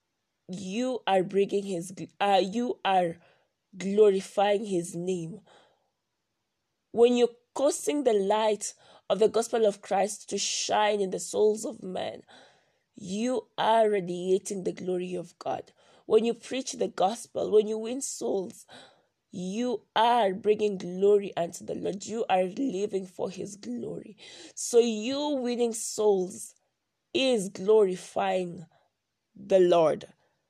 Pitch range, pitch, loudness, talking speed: 185-225 Hz, 200 Hz, -27 LUFS, 125 wpm